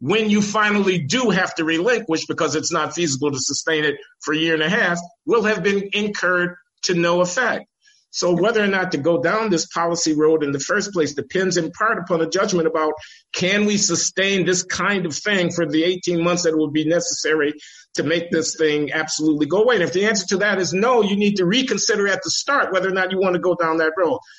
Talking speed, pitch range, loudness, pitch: 235 wpm, 160-200 Hz, -19 LUFS, 175 Hz